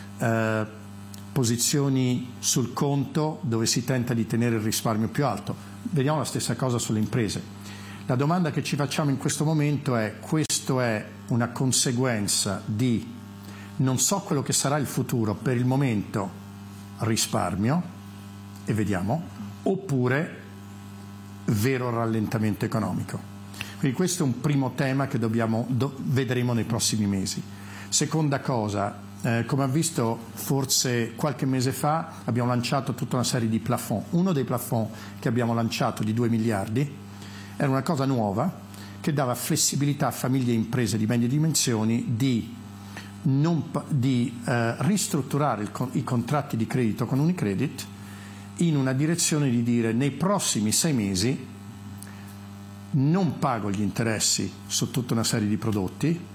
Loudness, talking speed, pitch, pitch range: -25 LUFS, 145 wpm, 120 Hz, 100-135 Hz